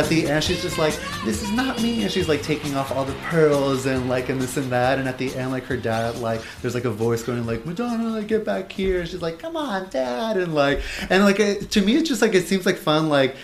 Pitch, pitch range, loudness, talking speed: 155 Hz, 130-195 Hz, -22 LUFS, 280 wpm